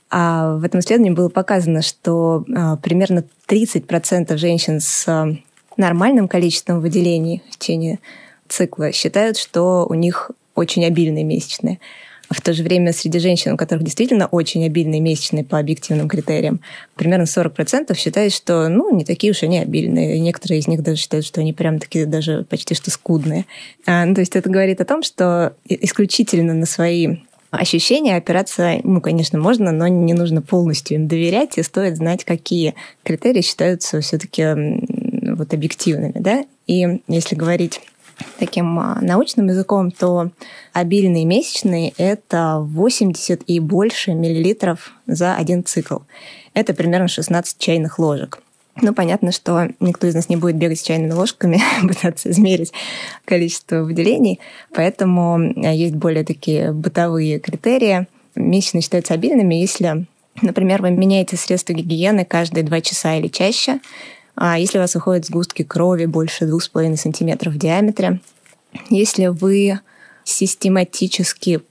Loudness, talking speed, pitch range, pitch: -17 LUFS, 145 wpm, 165-190 Hz, 175 Hz